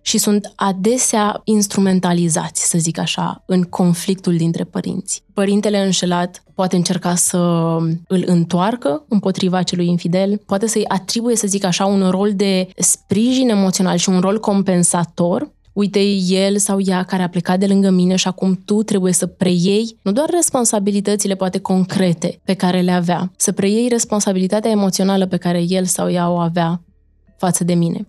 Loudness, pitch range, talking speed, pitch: -16 LUFS, 180-205 Hz, 160 wpm, 190 Hz